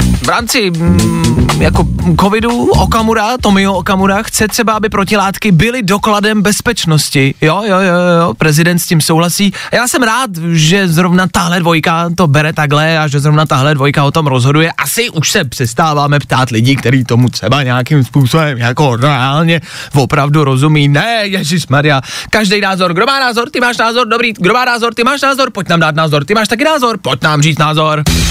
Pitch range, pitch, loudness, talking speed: 145-210 Hz, 170 Hz, -10 LUFS, 180 wpm